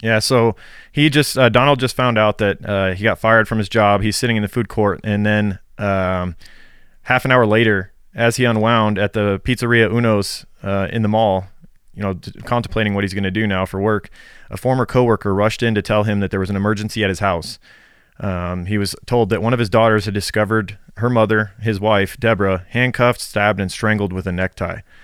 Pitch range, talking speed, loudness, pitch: 100-115 Hz, 220 wpm, -17 LUFS, 105 Hz